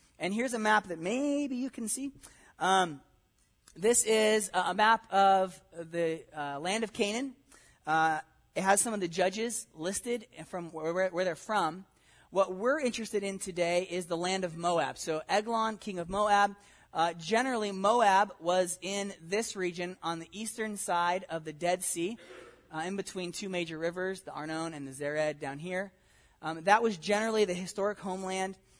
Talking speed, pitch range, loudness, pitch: 175 wpm, 170-210 Hz, -31 LUFS, 190 Hz